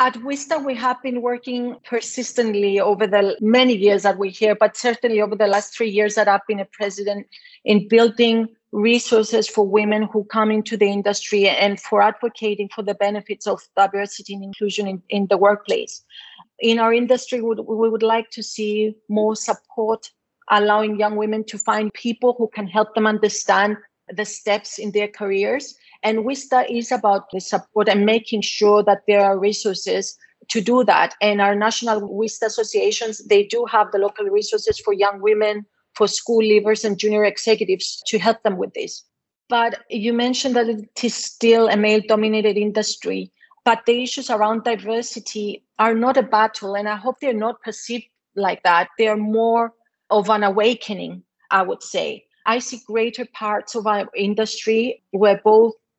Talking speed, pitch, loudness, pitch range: 175 wpm, 215 Hz, -19 LUFS, 205-230 Hz